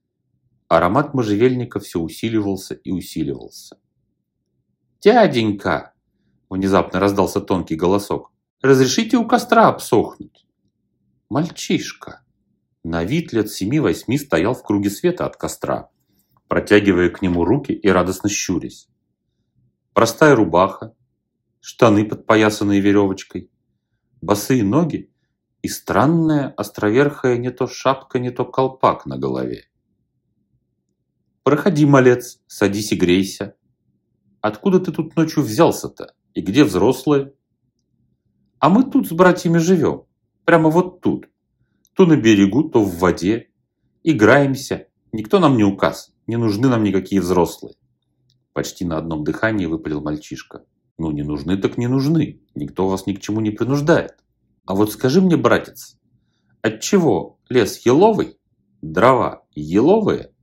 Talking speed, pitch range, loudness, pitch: 115 wpm, 95-140 Hz, -18 LUFS, 110 Hz